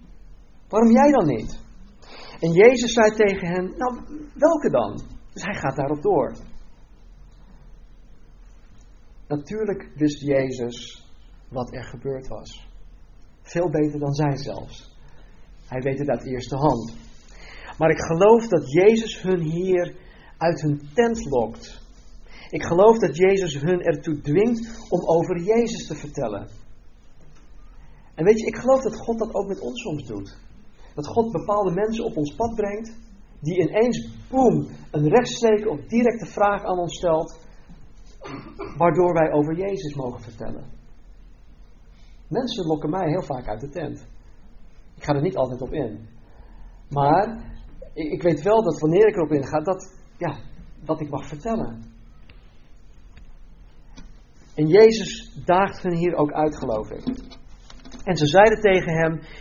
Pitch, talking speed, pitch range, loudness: 160 Hz, 140 wpm, 125-205 Hz, -22 LUFS